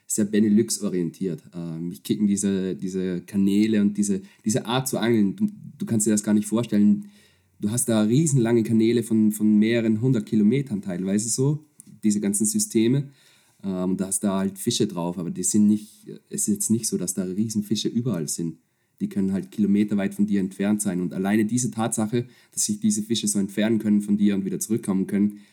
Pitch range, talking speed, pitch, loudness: 100-115 Hz, 200 wpm, 105 Hz, -23 LUFS